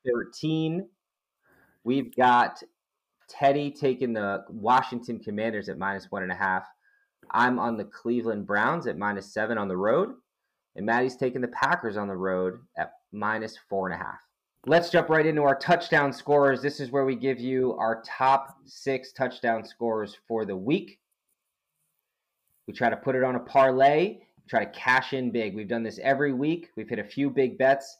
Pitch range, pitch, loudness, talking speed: 110-140 Hz, 130 Hz, -26 LUFS, 180 wpm